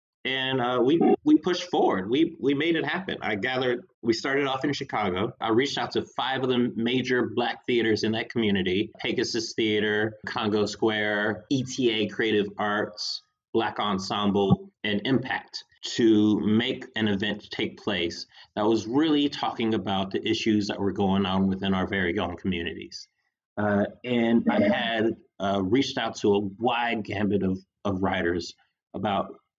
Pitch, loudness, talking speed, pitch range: 110 Hz, -26 LUFS, 160 wpm, 100-125 Hz